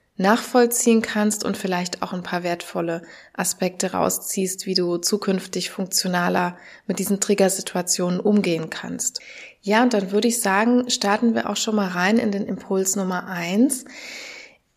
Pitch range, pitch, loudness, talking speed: 185-215 Hz, 195 Hz, -21 LUFS, 145 wpm